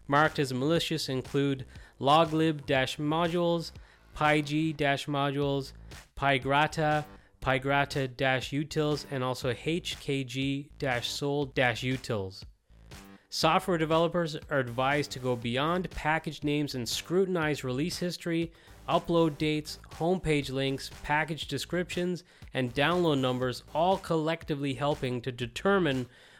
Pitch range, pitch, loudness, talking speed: 130-160 Hz, 145 Hz, -29 LUFS, 100 wpm